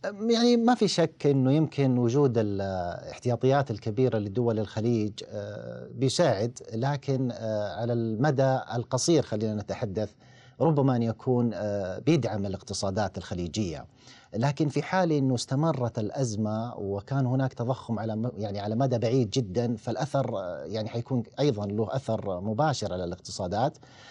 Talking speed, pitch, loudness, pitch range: 120 wpm, 120 Hz, -28 LUFS, 110-135 Hz